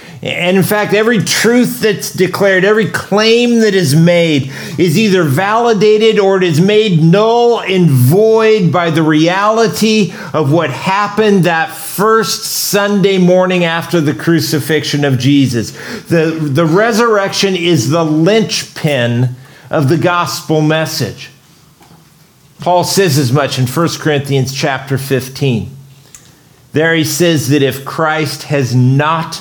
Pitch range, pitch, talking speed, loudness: 150-200 Hz, 165 Hz, 130 wpm, -11 LUFS